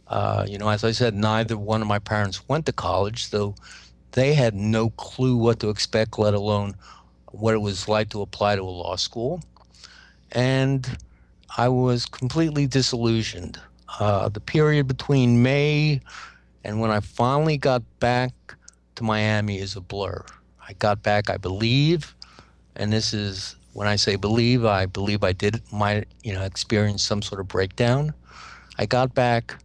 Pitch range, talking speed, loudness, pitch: 100-120 Hz, 165 wpm, -23 LUFS, 110 Hz